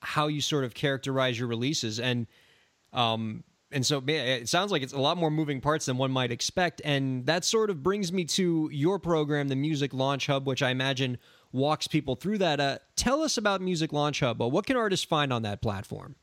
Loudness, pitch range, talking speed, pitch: -28 LUFS, 130-160 Hz, 220 wpm, 145 Hz